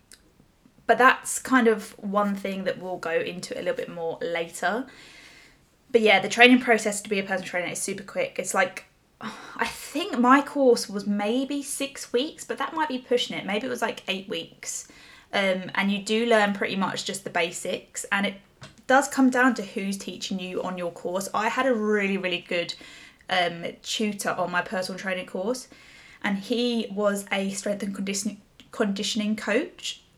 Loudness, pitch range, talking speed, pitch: -25 LUFS, 195-245 Hz, 190 wpm, 210 Hz